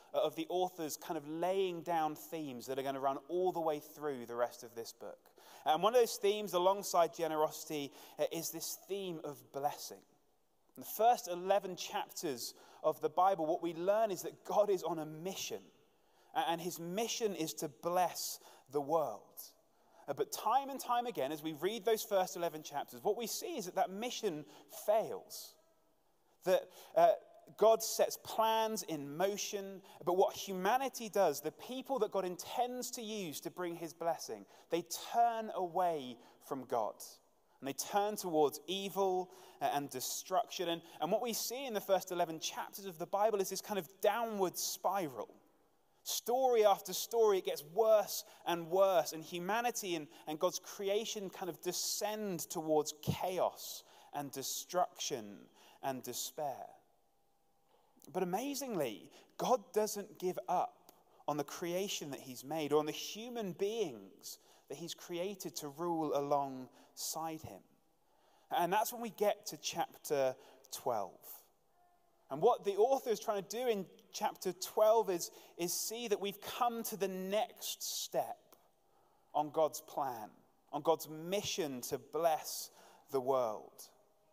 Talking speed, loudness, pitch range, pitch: 155 wpm, -37 LUFS, 160-220 Hz, 185 Hz